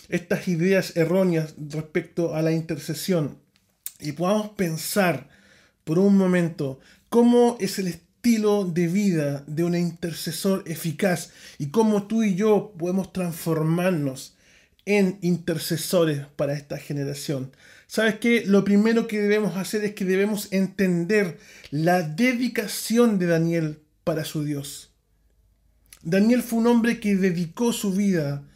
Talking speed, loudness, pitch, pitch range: 130 wpm, -23 LUFS, 180 Hz, 160-205 Hz